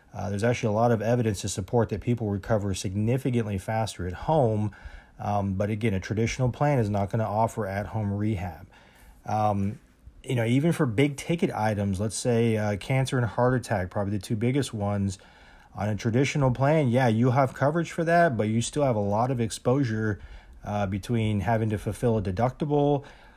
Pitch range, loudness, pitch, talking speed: 105-125 Hz, -26 LUFS, 110 Hz, 195 wpm